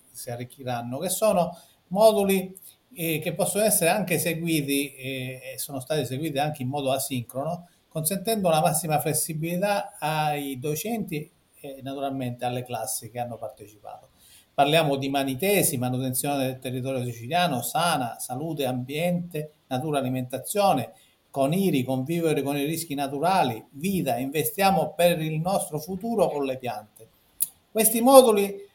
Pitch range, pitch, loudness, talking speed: 130-175 Hz, 150 Hz, -25 LUFS, 135 wpm